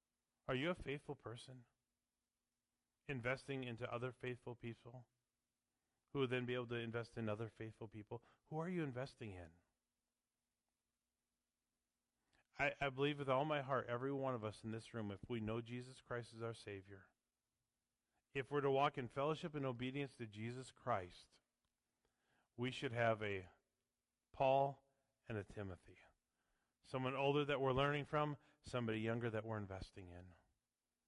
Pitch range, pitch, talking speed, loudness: 110-135 Hz, 125 Hz, 155 wpm, -44 LUFS